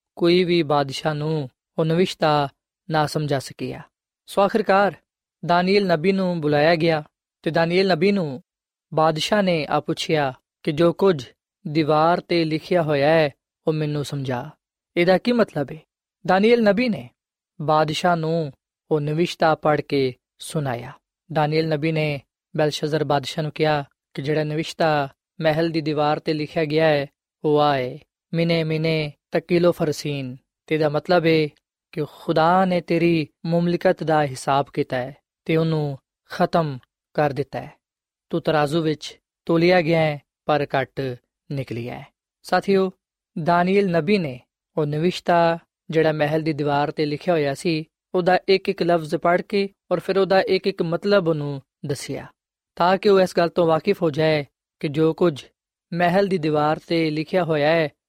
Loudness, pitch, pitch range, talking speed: -21 LUFS, 160 Hz, 150-175 Hz, 145 wpm